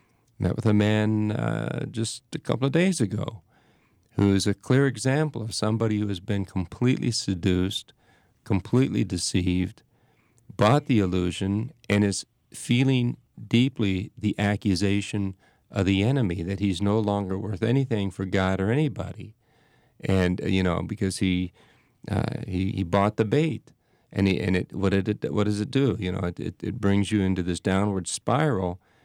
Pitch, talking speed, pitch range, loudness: 105 Hz, 165 wpm, 95-120 Hz, -25 LUFS